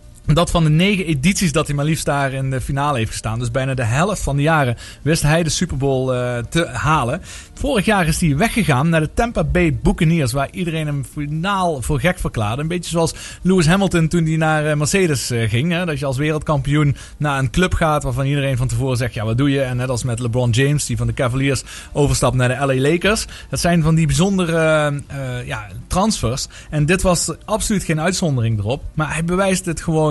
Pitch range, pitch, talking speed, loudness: 130-170 Hz, 150 Hz, 220 wpm, -18 LUFS